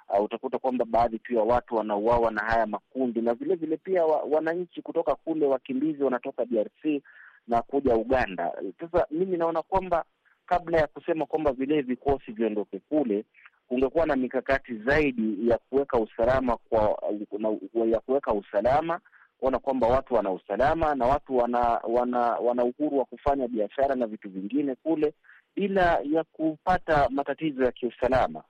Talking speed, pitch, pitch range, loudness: 150 wpm, 135 Hz, 120-155 Hz, -27 LUFS